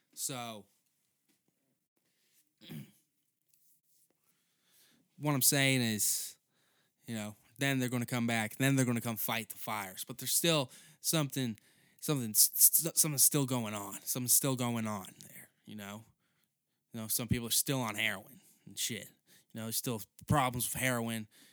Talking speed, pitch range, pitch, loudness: 155 wpm, 110-140 Hz, 125 Hz, -31 LUFS